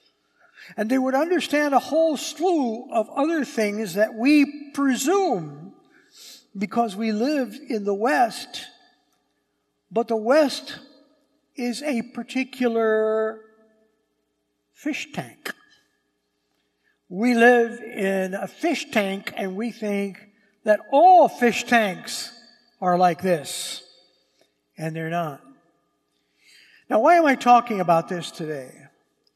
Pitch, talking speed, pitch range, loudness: 235 Hz, 110 wpm, 210-280 Hz, -22 LUFS